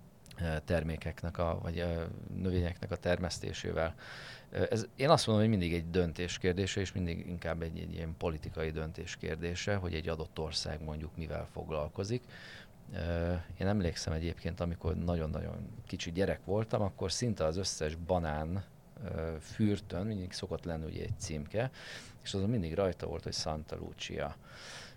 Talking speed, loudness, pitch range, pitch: 145 wpm, -36 LUFS, 80-100 Hz, 85 Hz